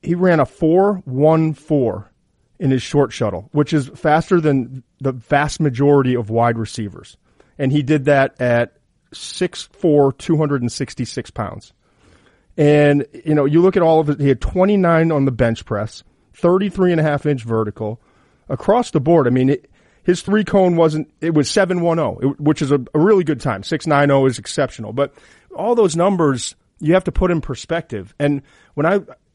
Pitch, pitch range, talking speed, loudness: 145 Hz, 130-165 Hz, 190 wpm, -17 LUFS